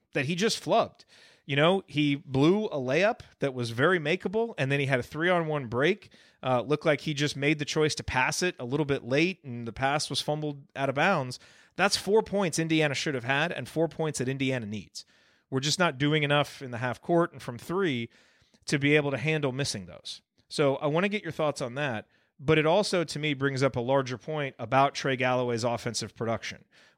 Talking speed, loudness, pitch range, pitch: 225 wpm, -28 LUFS, 130-160 Hz, 145 Hz